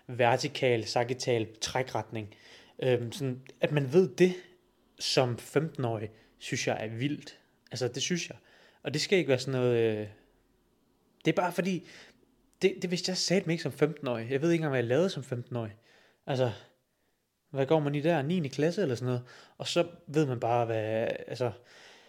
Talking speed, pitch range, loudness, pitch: 180 wpm, 120-160 Hz, -30 LUFS, 130 Hz